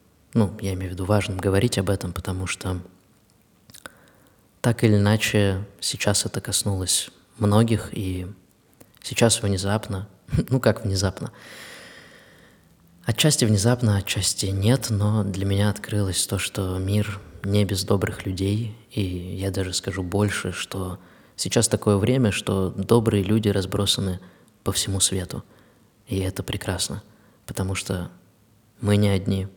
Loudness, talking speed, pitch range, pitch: -23 LUFS, 130 wpm, 95-110 Hz, 100 Hz